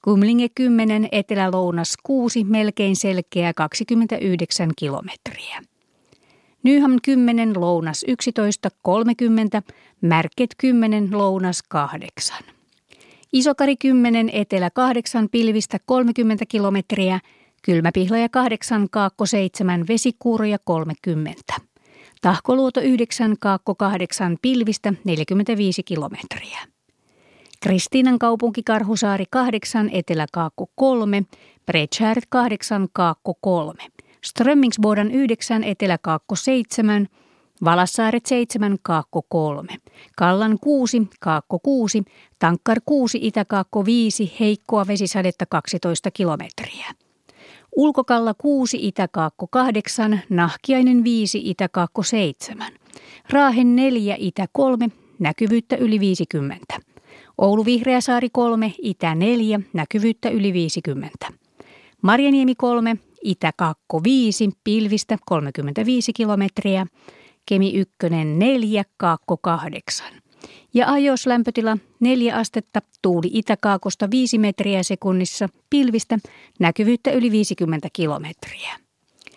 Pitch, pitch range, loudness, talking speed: 210 Hz, 185-235 Hz, -20 LUFS, 90 wpm